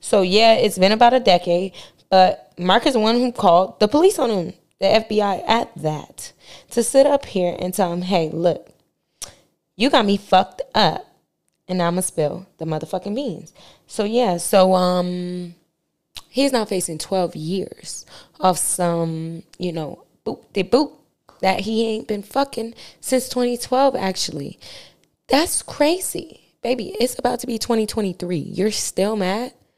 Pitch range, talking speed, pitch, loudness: 175-235 Hz, 165 wpm, 190 Hz, -19 LUFS